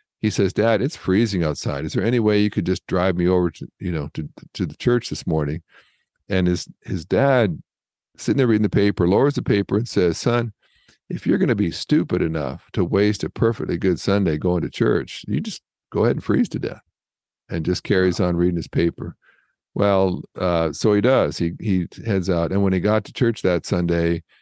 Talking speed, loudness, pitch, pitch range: 215 wpm, -21 LUFS, 95 Hz, 90-105 Hz